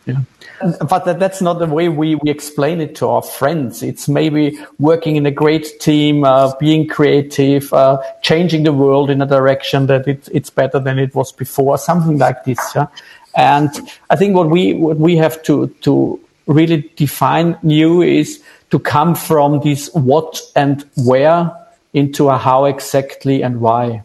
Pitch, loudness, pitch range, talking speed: 145 Hz, -14 LUFS, 135-160 Hz, 175 wpm